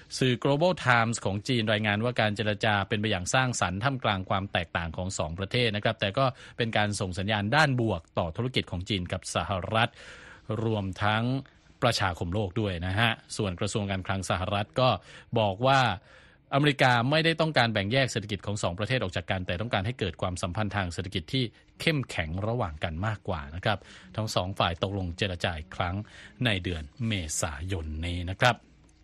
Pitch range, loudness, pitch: 95-120 Hz, -28 LUFS, 105 Hz